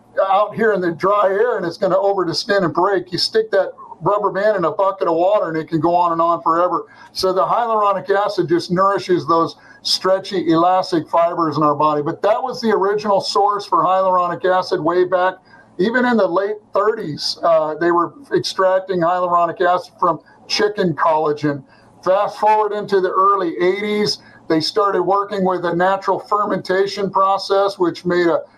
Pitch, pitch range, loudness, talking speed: 185 Hz, 170-200 Hz, -17 LUFS, 185 wpm